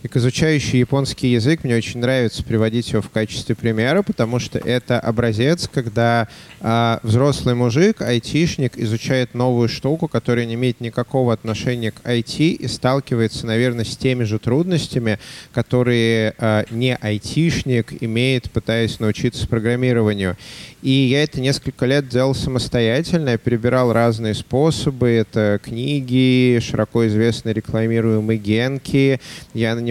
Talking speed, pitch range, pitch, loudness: 135 wpm, 115-130 Hz, 120 Hz, -19 LUFS